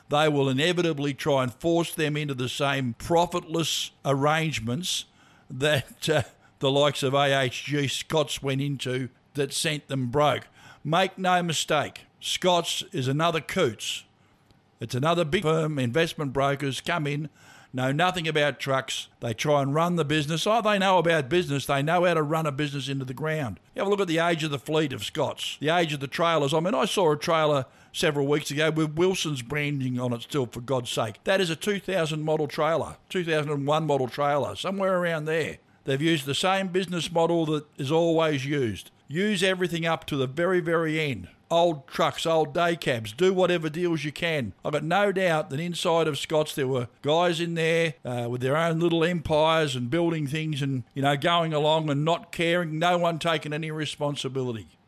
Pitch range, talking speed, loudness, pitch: 135-170 Hz, 190 wpm, -26 LUFS, 155 Hz